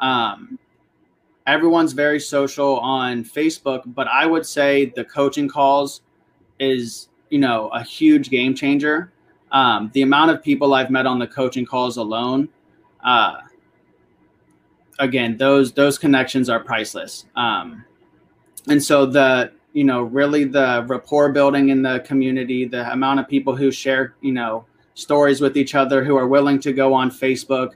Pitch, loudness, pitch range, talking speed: 135 Hz, -18 LUFS, 130-140 Hz, 155 wpm